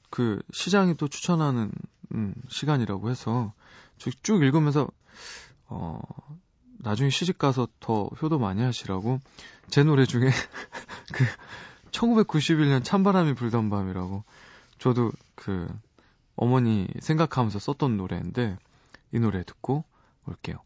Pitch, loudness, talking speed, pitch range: 130 Hz, -26 LUFS, 235 characters per minute, 115-150 Hz